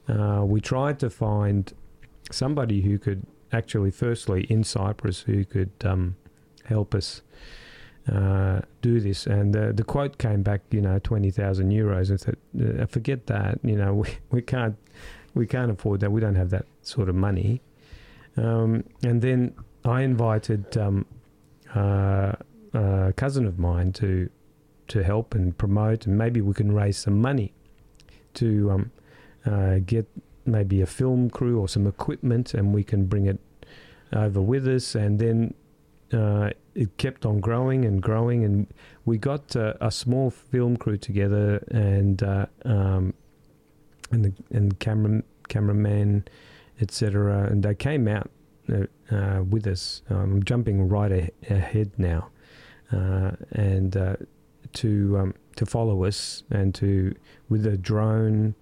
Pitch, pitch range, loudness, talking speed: 105 Hz, 100-120 Hz, -25 LUFS, 150 wpm